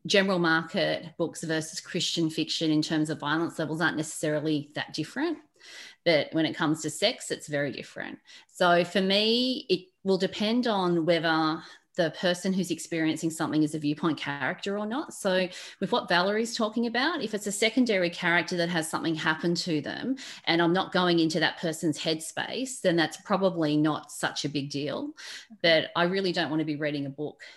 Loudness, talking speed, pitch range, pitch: -27 LUFS, 185 wpm, 155-200 Hz, 170 Hz